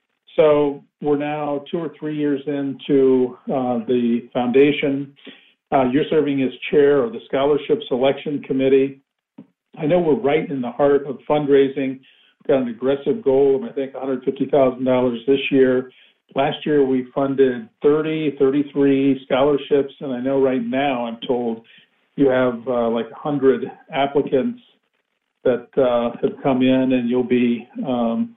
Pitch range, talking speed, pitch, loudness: 130-145 Hz, 150 wpm, 135 Hz, -19 LUFS